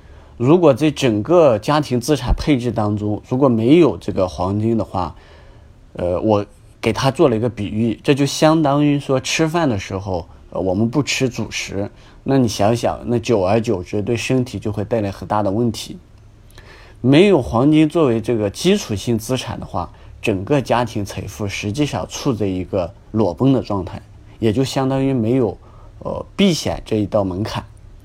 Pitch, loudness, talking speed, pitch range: 110 Hz, -18 LUFS, 255 characters per minute, 100-130 Hz